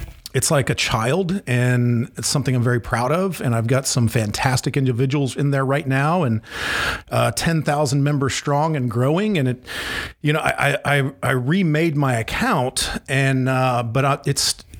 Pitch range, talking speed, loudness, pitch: 125-150 Hz, 180 wpm, -20 LUFS, 135 Hz